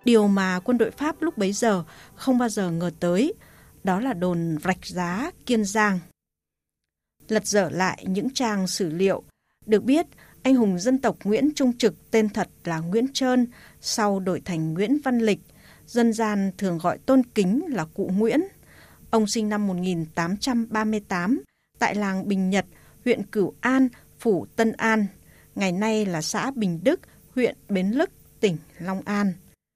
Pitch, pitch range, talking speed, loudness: 210 Hz, 185-235 Hz, 165 wpm, -24 LUFS